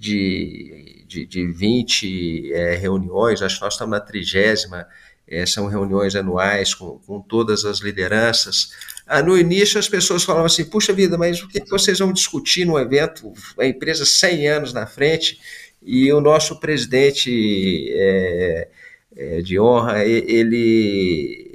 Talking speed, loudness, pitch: 155 wpm, -17 LUFS, 120 Hz